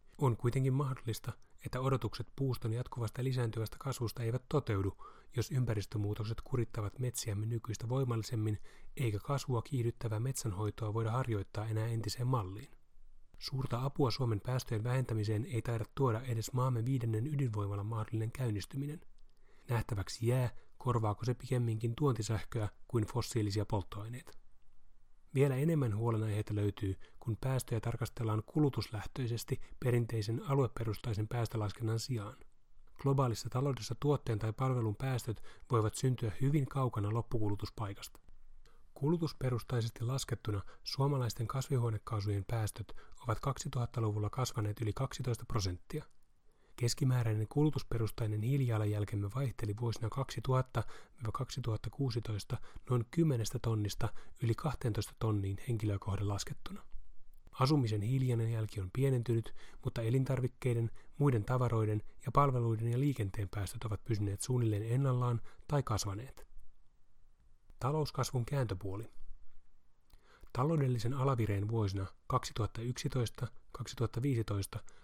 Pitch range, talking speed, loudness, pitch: 105-130 Hz, 100 wpm, -36 LUFS, 115 Hz